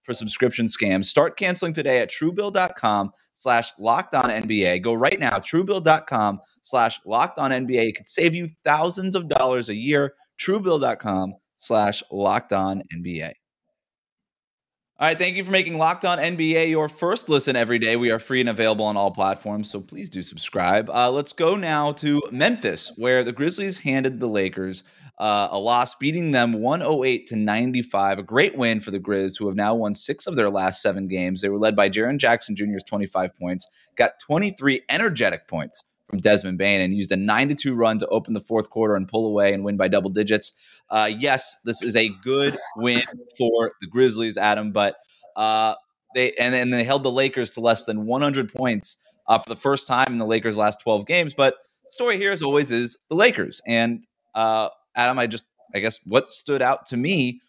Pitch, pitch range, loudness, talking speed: 115 Hz, 105-140 Hz, -22 LUFS, 200 wpm